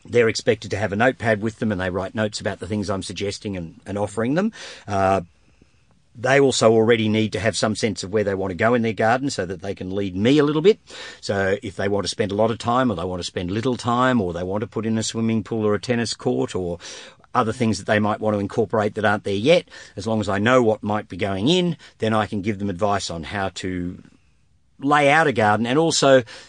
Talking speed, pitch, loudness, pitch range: 265 wpm, 110 Hz, -21 LUFS, 100-120 Hz